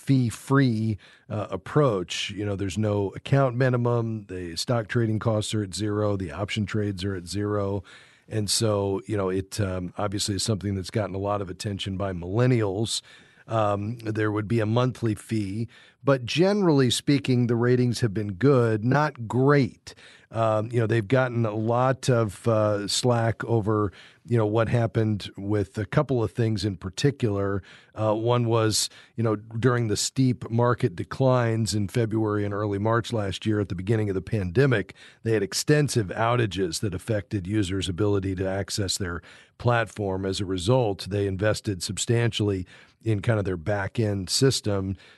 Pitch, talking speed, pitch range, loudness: 110 Hz, 165 wpm, 100-120 Hz, -25 LUFS